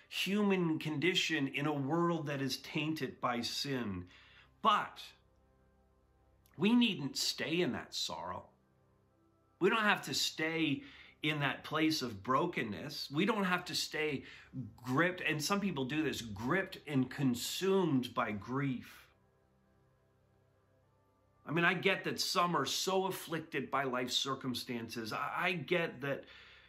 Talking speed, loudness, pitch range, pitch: 130 wpm, -35 LUFS, 120-165 Hz, 135 Hz